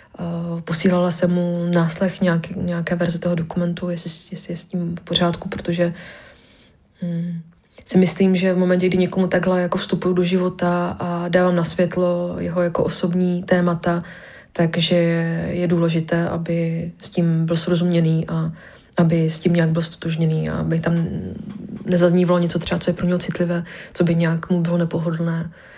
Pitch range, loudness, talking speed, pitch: 170-180 Hz, -20 LUFS, 160 wpm, 175 Hz